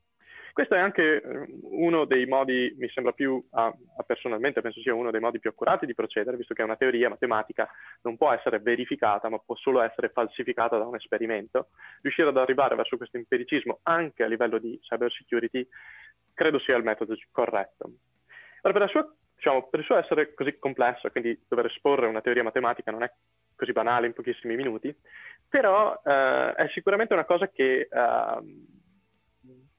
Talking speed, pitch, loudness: 175 wpm, 130 Hz, -26 LUFS